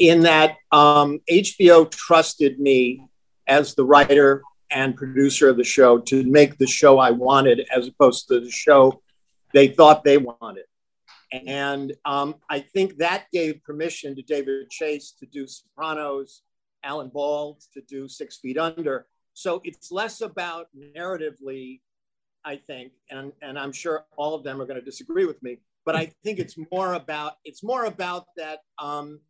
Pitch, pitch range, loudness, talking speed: 145 Hz, 135-160 Hz, -18 LUFS, 165 wpm